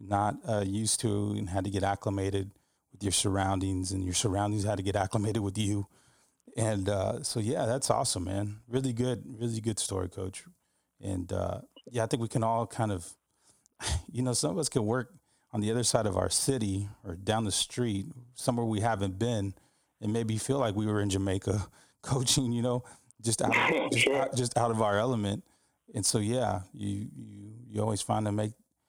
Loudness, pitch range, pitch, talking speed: -31 LUFS, 100-120 Hz, 105 Hz, 200 wpm